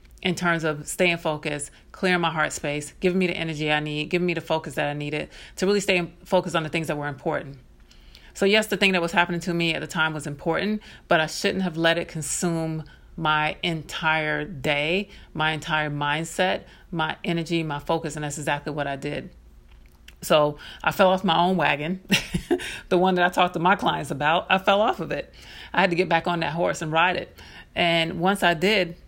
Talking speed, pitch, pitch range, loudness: 215 wpm, 165 Hz, 150-180 Hz, -24 LUFS